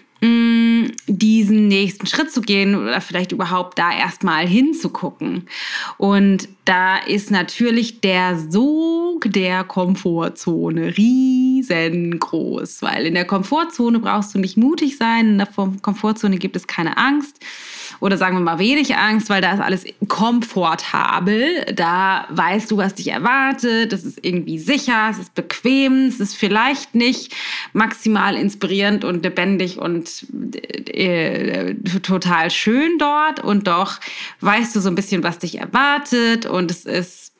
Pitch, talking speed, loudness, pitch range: 205 Hz, 140 wpm, -18 LUFS, 185-240 Hz